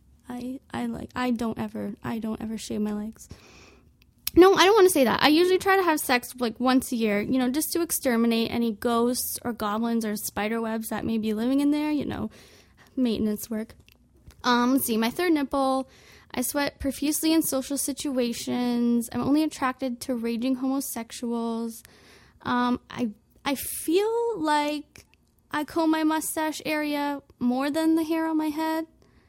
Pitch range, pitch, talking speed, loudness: 230-300 Hz, 255 Hz, 175 wpm, -25 LUFS